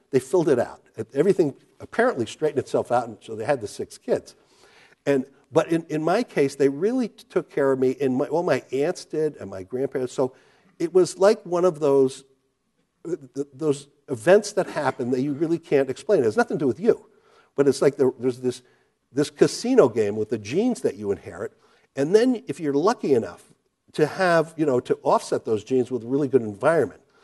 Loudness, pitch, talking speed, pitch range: -23 LUFS, 145 Hz, 215 wpm, 130-185 Hz